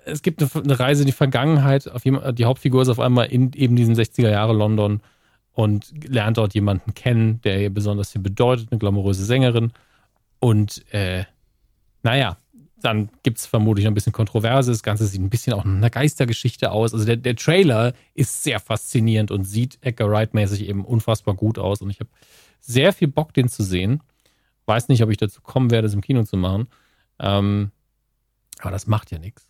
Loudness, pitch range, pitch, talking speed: -20 LUFS, 105-130 Hz, 115 Hz, 190 wpm